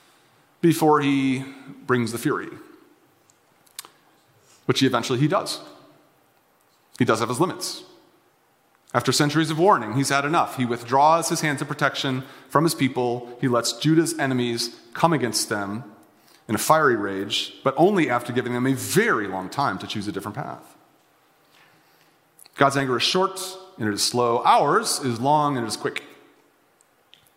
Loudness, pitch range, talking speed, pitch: -22 LUFS, 120-150 Hz, 150 wpm, 135 Hz